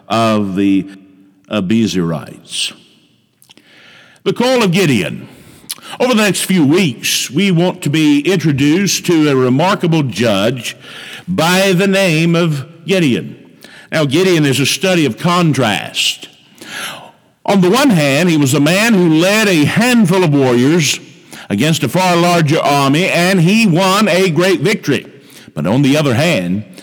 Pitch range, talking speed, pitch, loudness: 140-185 Hz, 140 wpm, 165 Hz, -12 LUFS